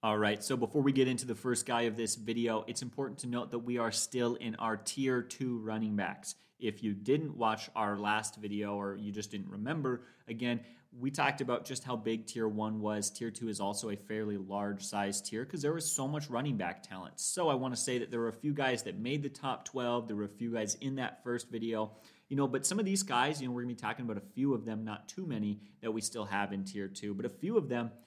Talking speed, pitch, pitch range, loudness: 265 wpm, 115 Hz, 105-130 Hz, -35 LUFS